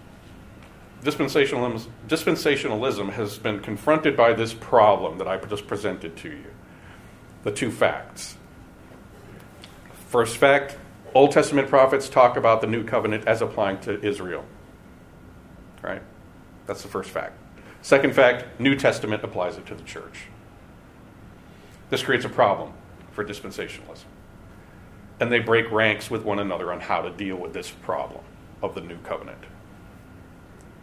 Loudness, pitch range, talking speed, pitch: -23 LUFS, 95-120 Hz, 135 wpm, 105 Hz